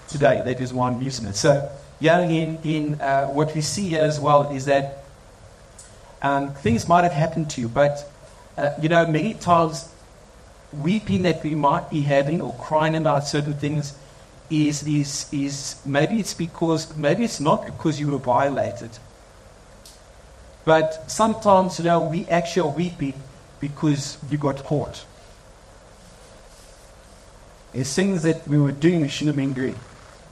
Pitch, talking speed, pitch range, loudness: 145 Hz, 155 wpm, 135-160 Hz, -22 LUFS